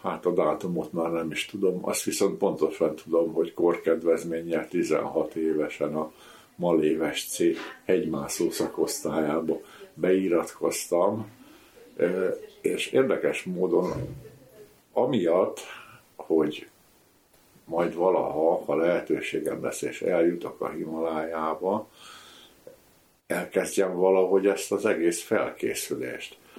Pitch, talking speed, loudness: 85 Hz, 90 wpm, -27 LUFS